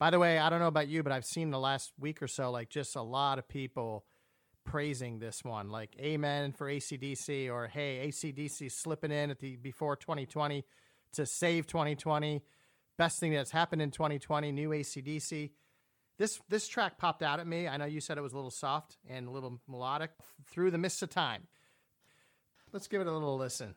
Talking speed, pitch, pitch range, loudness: 230 wpm, 145 Hz, 135-155 Hz, -35 LUFS